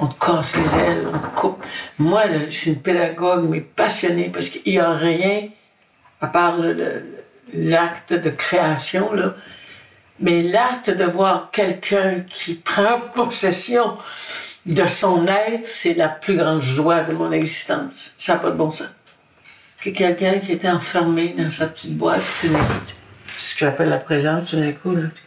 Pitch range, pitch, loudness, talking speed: 160-195 Hz, 175 Hz, -19 LUFS, 170 wpm